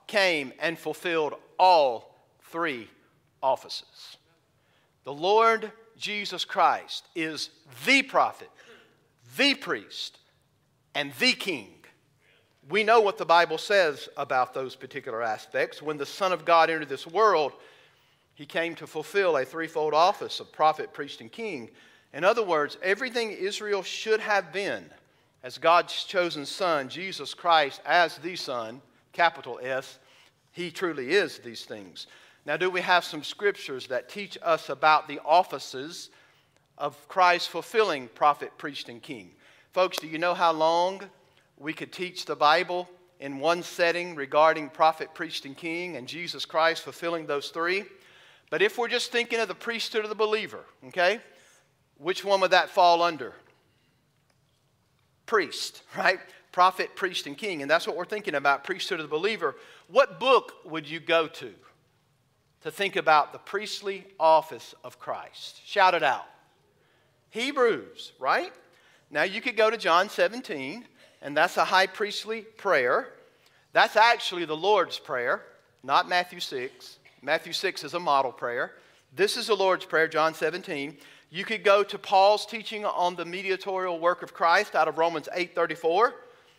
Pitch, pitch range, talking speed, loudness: 175 Hz, 150-200 Hz, 150 wpm, -26 LUFS